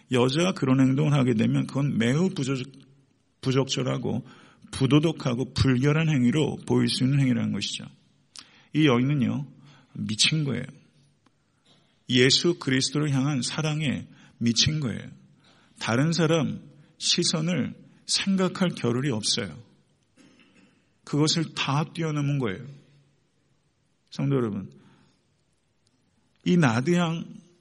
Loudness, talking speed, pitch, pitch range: -25 LUFS, 235 characters per minute, 140 Hz, 125-155 Hz